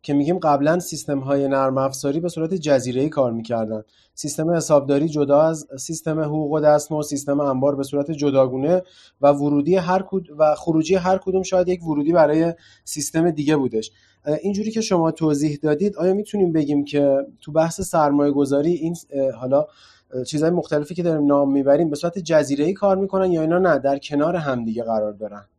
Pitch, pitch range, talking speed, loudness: 150 Hz, 140-170 Hz, 180 wpm, -20 LUFS